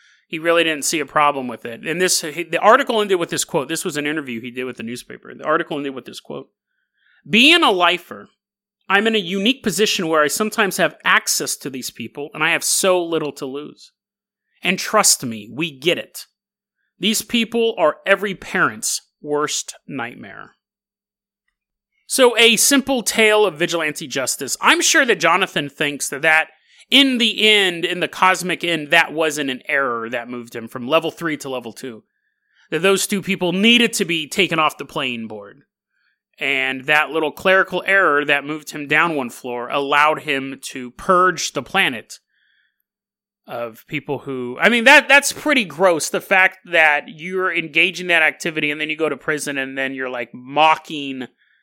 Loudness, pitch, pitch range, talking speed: -17 LUFS, 165 Hz, 145-200 Hz, 180 wpm